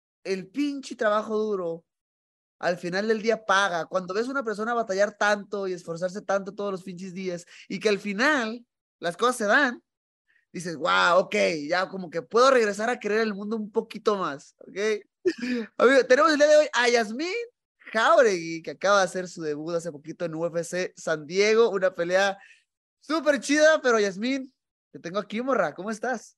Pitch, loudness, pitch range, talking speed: 210 Hz, -25 LUFS, 185-240 Hz, 180 wpm